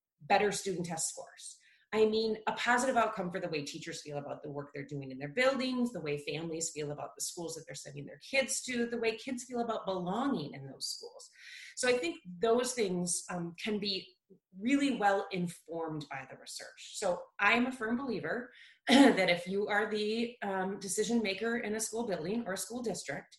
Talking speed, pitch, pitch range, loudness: 205 wpm, 200 Hz, 170-235 Hz, -33 LUFS